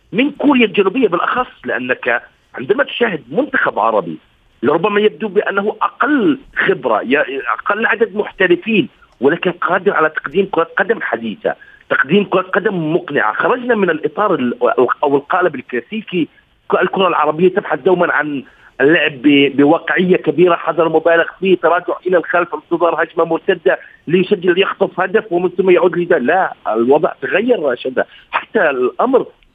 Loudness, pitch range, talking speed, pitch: -15 LUFS, 165-210 Hz, 130 wpm, 185 Hz